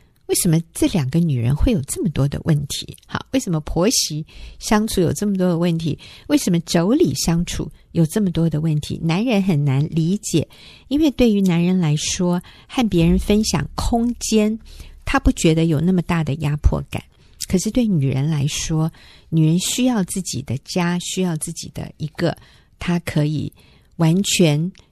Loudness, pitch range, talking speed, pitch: -19 LUFS, 155-200 Hz, 255 characters per minute, 170 Hz